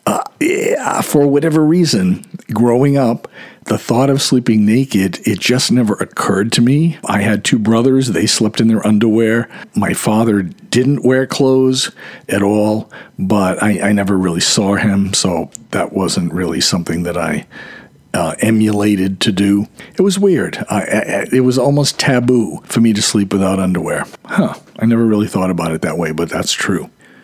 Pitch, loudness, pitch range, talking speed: 115 Hz, -14 LUFS, 100-130 Hz, 175 wpm